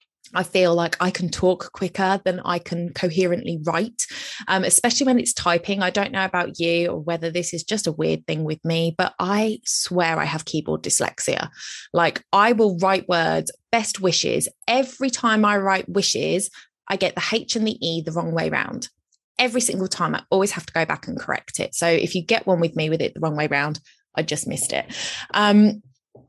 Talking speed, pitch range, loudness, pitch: 210 wpm, 165-200 Hz, -21 LUFS, 180 Hz